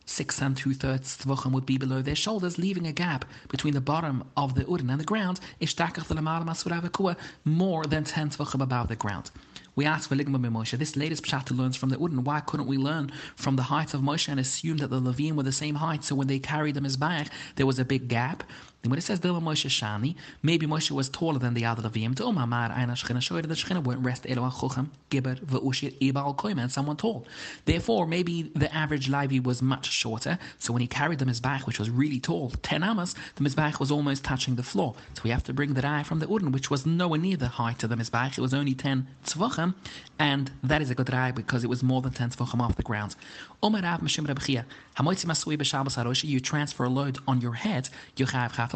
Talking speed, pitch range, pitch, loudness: 210 wpm, 130-155 Hz, 140 Hz, -28 LUFS